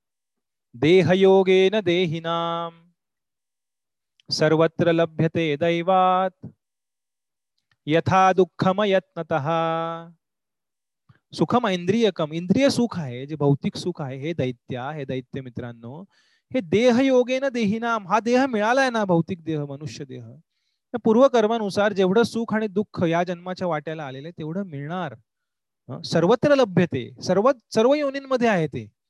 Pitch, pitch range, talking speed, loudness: 180 Hz, 160-215 Hz, 100 wpm, -22 LUFS